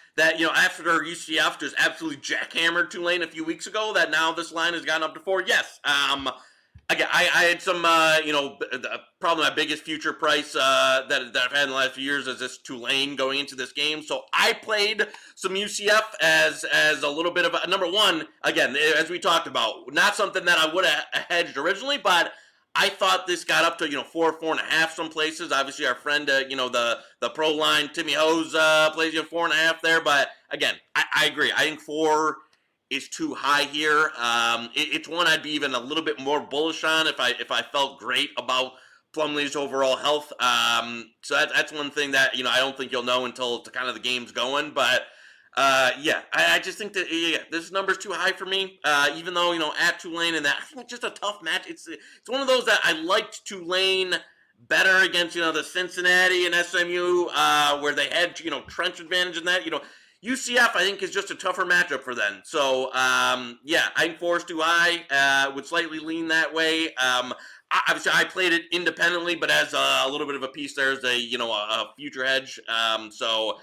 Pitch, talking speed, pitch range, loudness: 155 Hz, 230 wpm, 140-175 Hz, -23 LUFS